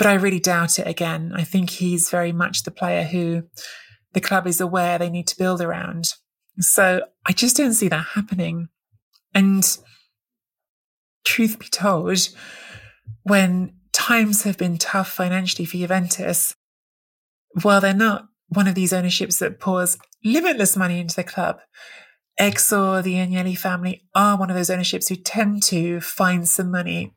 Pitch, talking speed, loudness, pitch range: 185 Hz, 155 wpm, -20 LUFS, 175-195 Hz